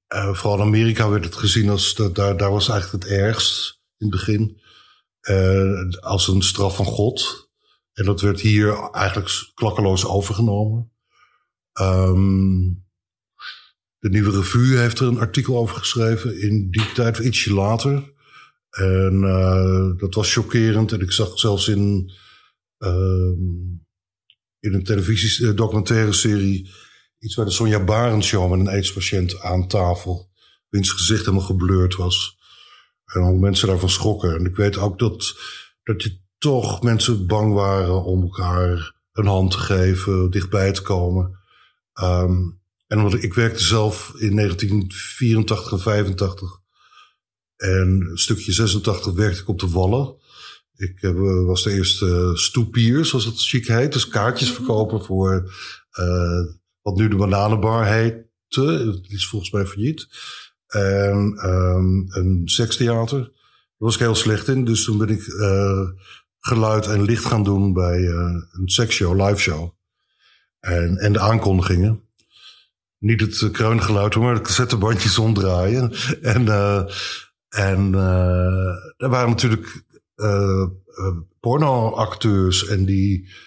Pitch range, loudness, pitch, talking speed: 95-110 Hz, -19 LUFS, 100 Hz, 140 wpm